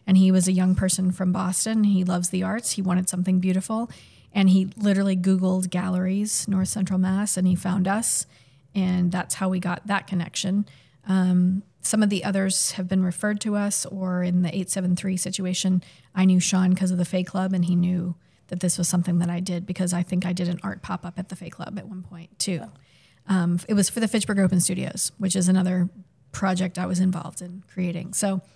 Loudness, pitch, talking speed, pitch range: -23 LUFS, 185 Hz, 220 wpm, 180-190 Hz